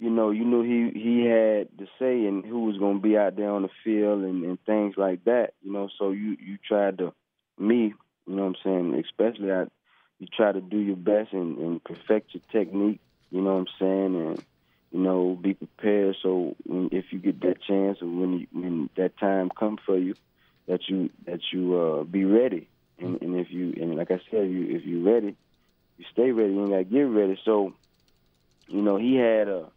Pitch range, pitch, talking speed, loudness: 90-105 Hz, 95 Hz, 220 wpm, -26 LUFS